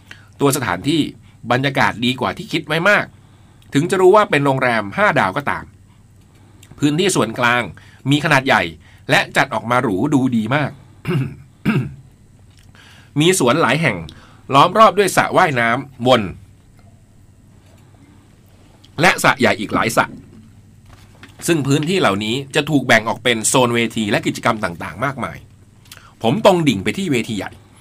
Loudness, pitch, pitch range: -16 LUFS, 115 Hz, 105-135 Hz